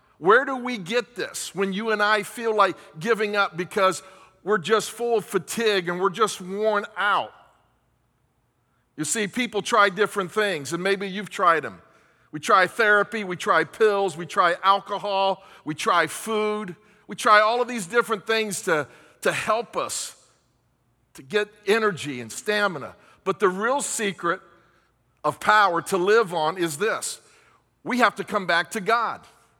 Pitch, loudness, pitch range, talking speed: 200 Hz, -23 LUFS, 175-215 Hz, 165 wpm